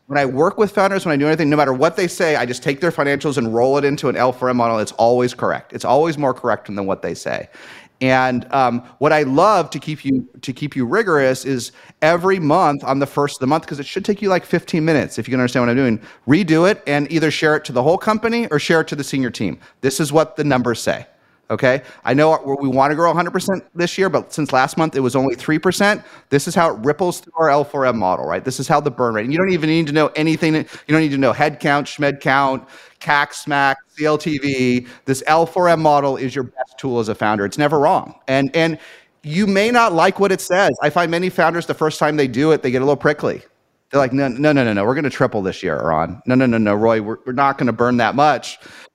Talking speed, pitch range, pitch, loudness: 260 wpm, 130-160 Hz, 145 Hz, -17 LUFS